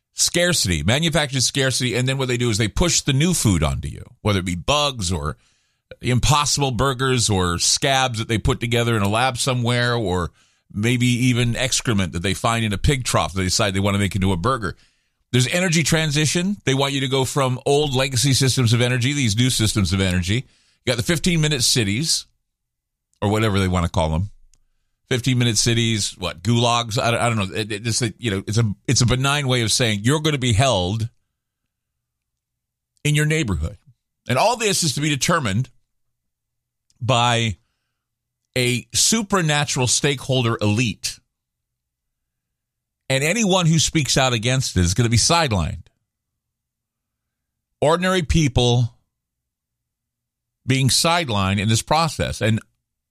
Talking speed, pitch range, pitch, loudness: 170 wpm, 105-135 Hz, 120 Hz, -19 LUFS